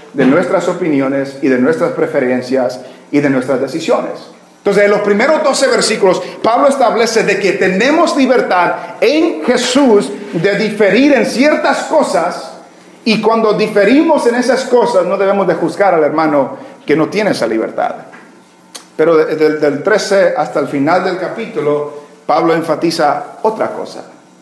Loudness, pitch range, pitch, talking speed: -12 LUFS, 155-240 Hz, 200 Hz, 145 wpm